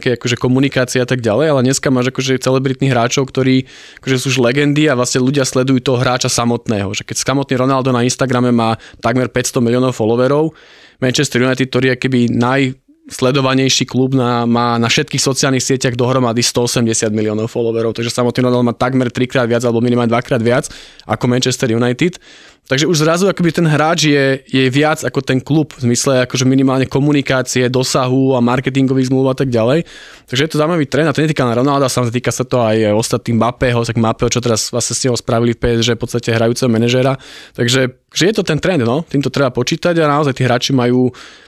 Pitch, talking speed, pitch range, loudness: 130 Hz, 200 wpm, 120-135 Hz, -14 LUFS